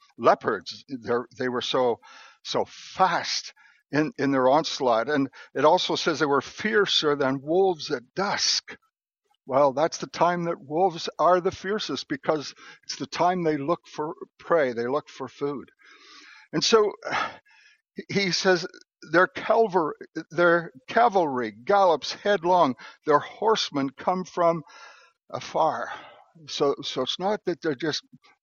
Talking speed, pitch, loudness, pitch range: 135 wpm, 175 Hz, -25 LUFS, 145-210 Hz